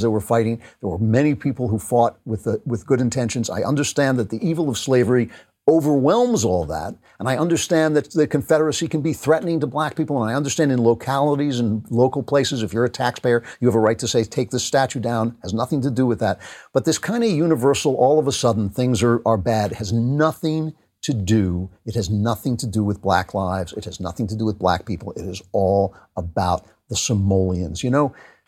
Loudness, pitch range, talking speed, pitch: -20 LUFS, 110-145 Hz, 225 wpm, 120 Hz